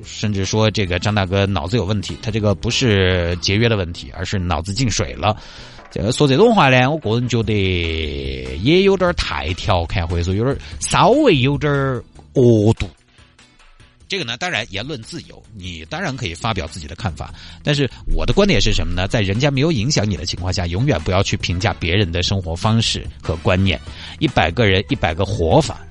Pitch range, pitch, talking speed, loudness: 85-115 Hz, 100 Hz, 290 characters per minute, -18 LUFS